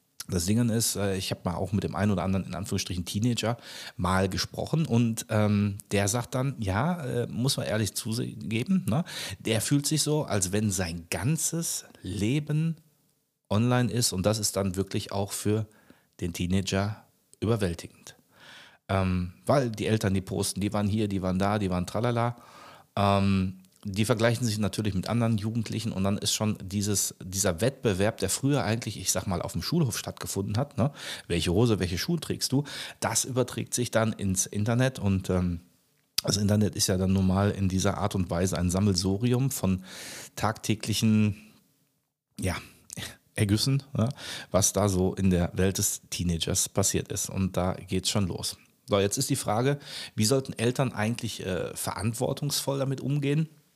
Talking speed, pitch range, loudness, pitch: 170 wpm, 95-120 Hz, -28 LUFS, 105 Hz